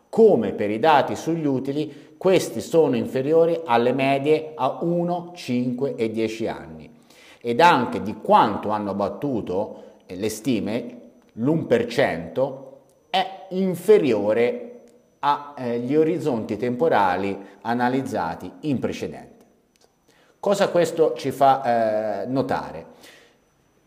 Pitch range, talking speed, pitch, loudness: 115-175 Hz, 100 wpm, 145 Hz, -22 LUFS